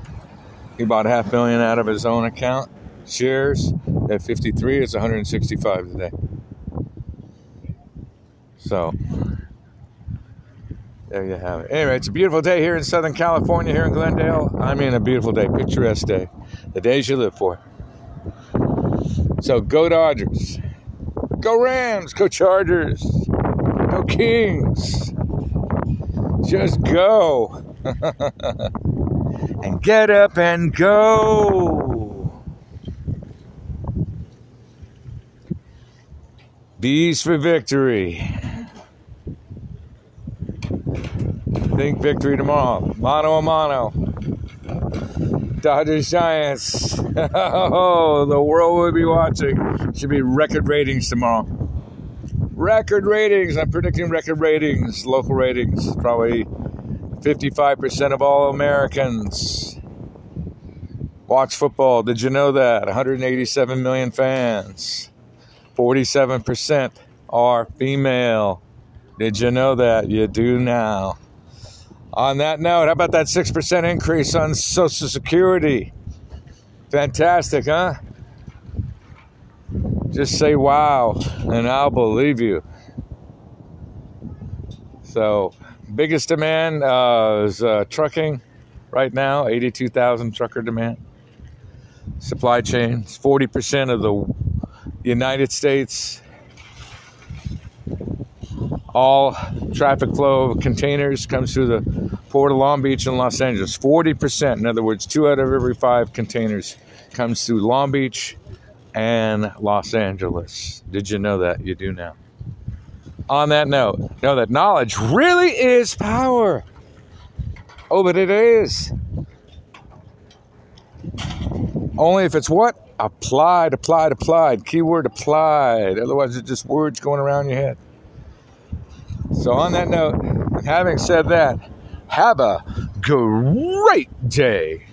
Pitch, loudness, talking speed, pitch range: 130 Hz, -18 LUFS, 105 wpm, 115-155 Hz